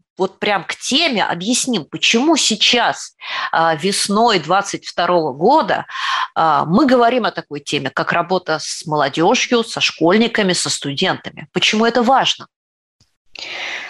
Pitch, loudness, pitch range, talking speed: 195 Hz, -16 LUFS, 170-235 Hz, 110 wpm